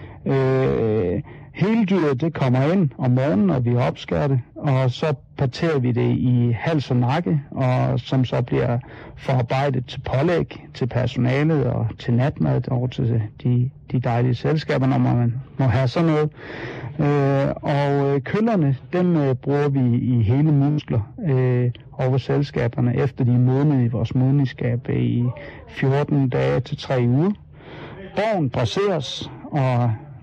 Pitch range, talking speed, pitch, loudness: 125-145 Hz, 145 wpm, 135 Hz, -21 LUFS